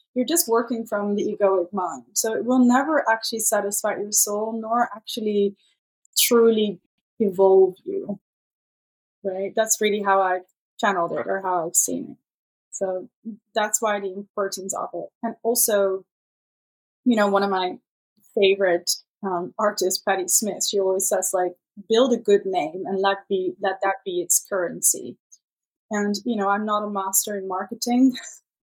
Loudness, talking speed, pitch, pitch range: -22 LUFS, 160 wpm, 205 Hz, 190-225 Hz